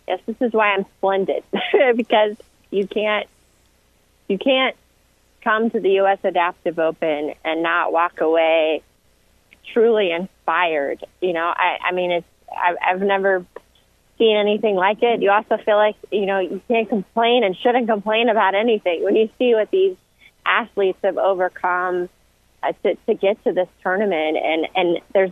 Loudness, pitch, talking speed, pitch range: -19 LUFS, 195 Hz, 160 wpm, 175-220 Hz